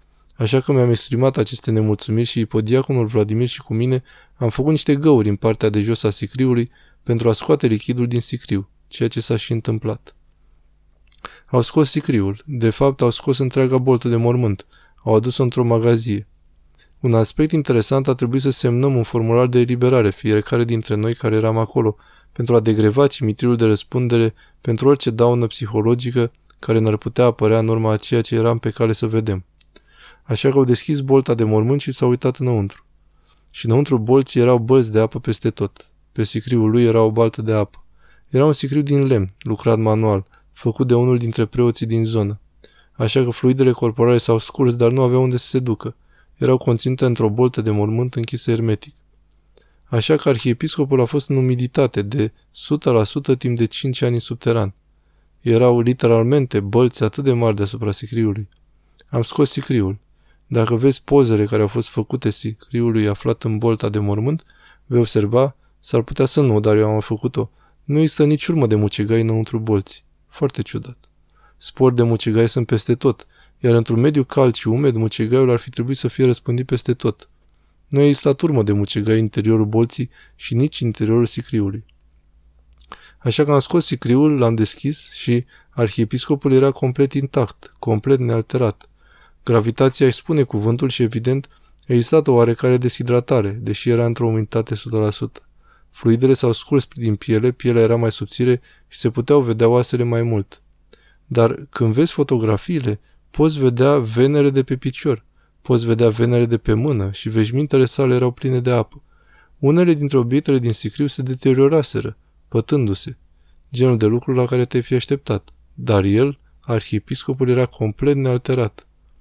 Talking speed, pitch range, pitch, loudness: 170 wpm, 110-130 Hz, 120 Hz, -18 LUFS